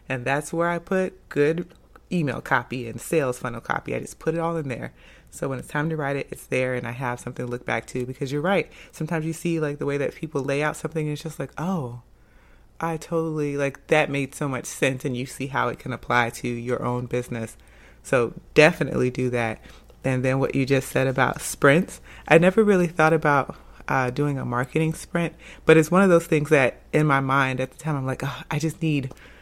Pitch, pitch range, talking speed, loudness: 140 Hz, 125-160 Hz, 235 wpm, -24 LUFS